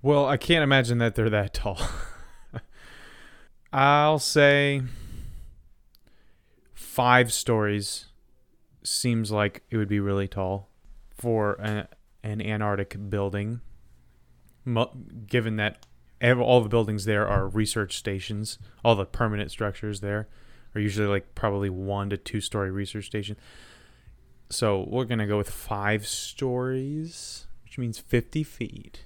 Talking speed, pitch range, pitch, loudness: 125 wpm, 100-120 Hz, 105 Hz, -26 LUFS